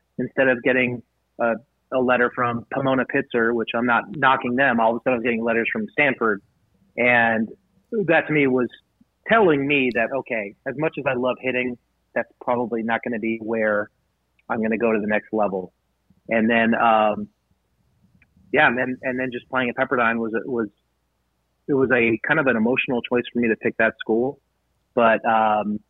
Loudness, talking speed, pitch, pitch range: -21 LUFS, 195 wpm, 120 Hz, 115-130 Hz